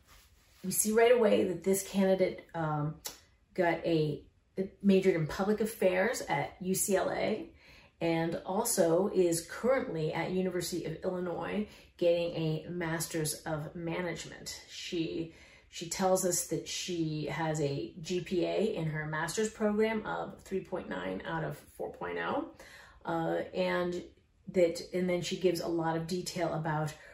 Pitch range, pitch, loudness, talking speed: 160-185 Hz, 170 Hz, -32 LUFS, 130 wpm